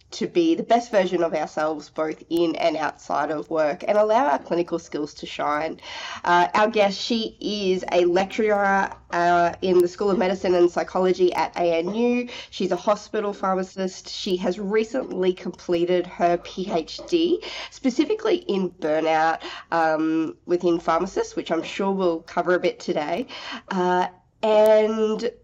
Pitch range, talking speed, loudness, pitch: 175-215 Hz, 150 wpm, -23 LUFS, 185 Hz